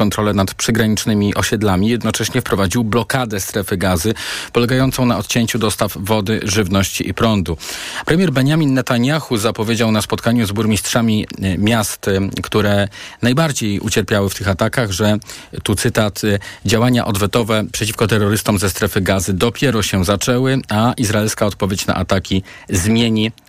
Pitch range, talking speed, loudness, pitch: 100-120 Hz, 130 wpm, -16 LUFS, 110 Hz